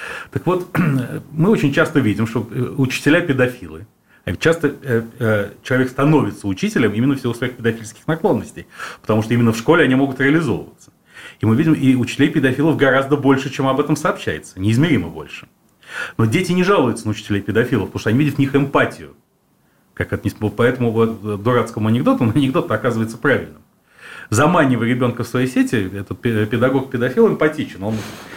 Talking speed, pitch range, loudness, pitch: 160 wpm, 110-145 Hz, -18 LUFS, 125 Hz